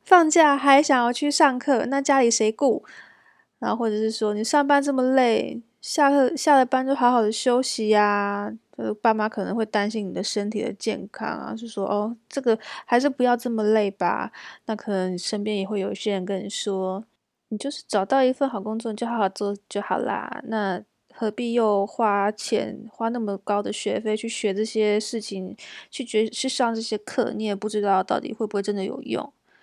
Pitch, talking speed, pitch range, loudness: 220 Hz, 285 characters per minute, 205-255 Hz, -23 LUFS